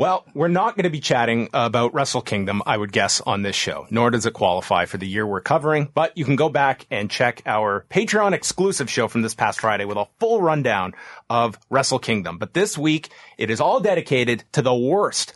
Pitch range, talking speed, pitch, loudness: 110-155 Hz, 225 wpm, 130 Hz, -21 LUFS